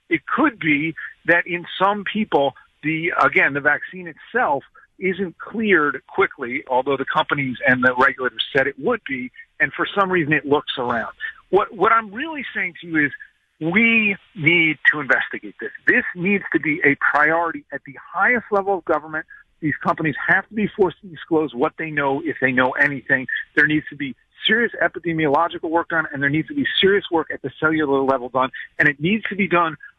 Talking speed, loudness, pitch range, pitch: 195 wpm, -19 LUFS, 145-200 Hz, 165 Hz